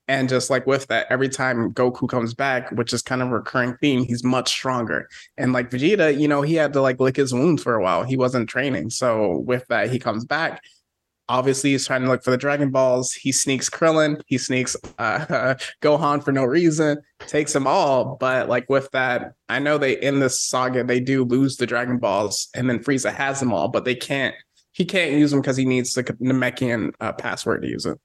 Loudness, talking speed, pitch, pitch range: -21 LUFS, 225 wpm, 130 Hz, 125-140 Hz